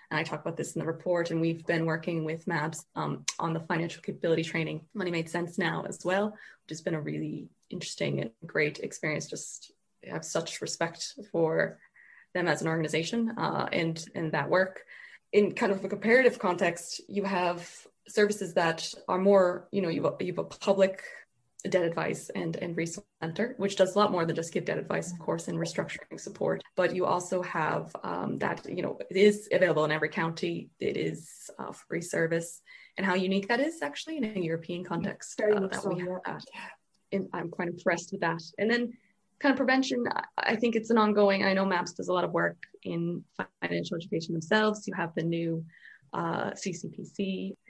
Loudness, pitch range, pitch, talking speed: -30 LUFS, 165-200 Hz, 180 Hz, 195 wpm